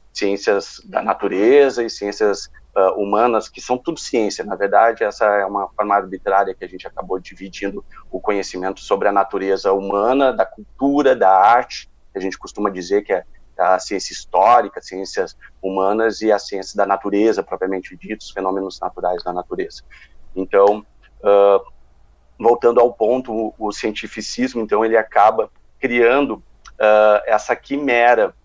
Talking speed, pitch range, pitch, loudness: 150 wpm, 95-115 Hz, 100 Hz, -18 LUFS